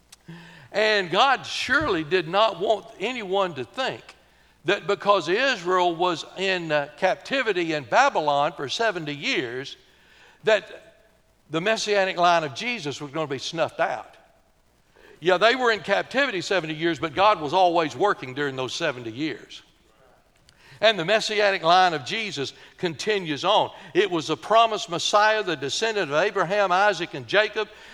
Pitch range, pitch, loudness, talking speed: 155-215 Hz, 185 Hz, -23 LUFS, 145 wpm